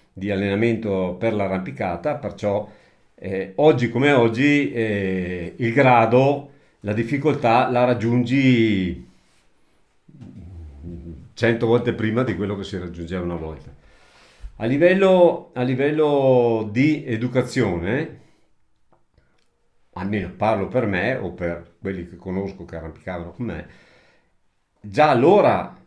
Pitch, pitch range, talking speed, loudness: 110 Hz, 95-125 Hz, 110 wpm, -20 LUFS